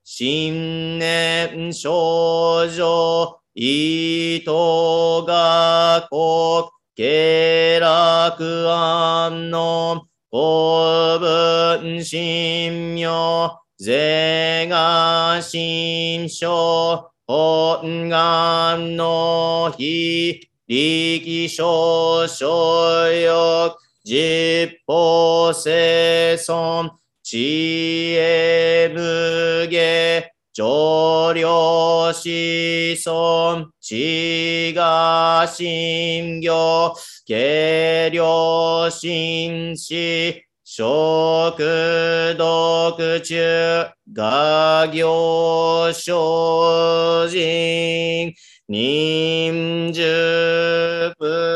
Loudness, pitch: -17 LUFS, 165 Hz